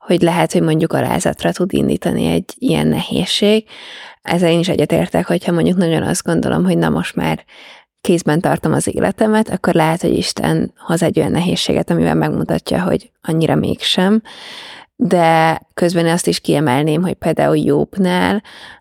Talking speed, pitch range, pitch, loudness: 155 wpm, 160-185 Hz, 170 Hz, -15 LUFS